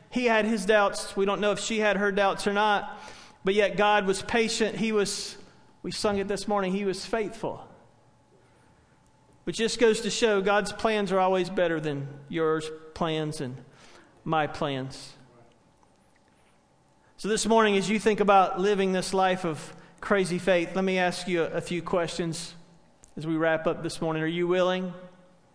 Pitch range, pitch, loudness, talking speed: 165-205 Hz, 190 Hz, -26 LUFS, 175 wpm